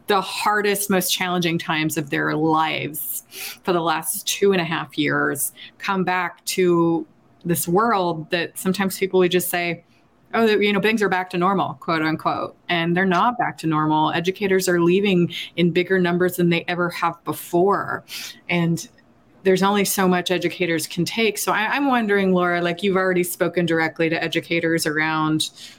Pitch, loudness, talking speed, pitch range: 175 Hz, -21 LUFS, 175 wpm, 165-190 Hz